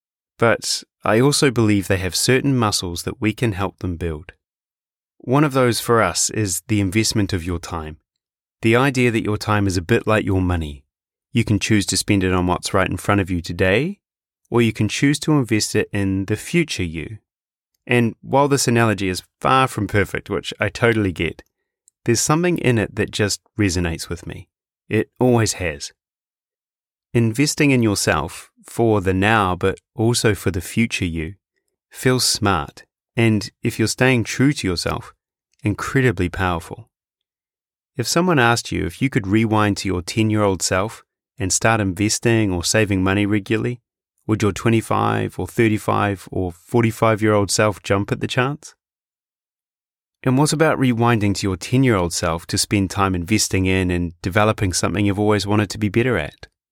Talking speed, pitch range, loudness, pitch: 180 wpm, 95-115 Hz, -19 LUFS, 105 Hz